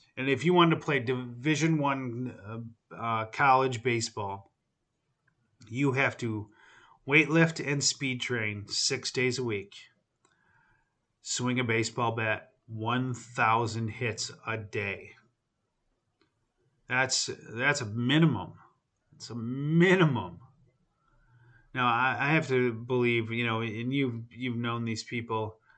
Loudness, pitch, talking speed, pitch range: -28 LUFS, 125 Hz, 125 wpm, 115-135 Hz